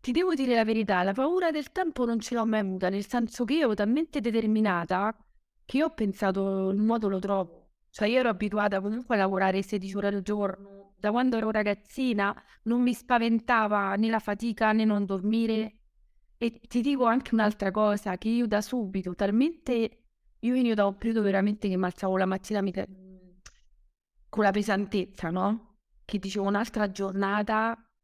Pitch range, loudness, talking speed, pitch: 195-230 Hz, -28 LUFS, 175 wpm, 210 Hz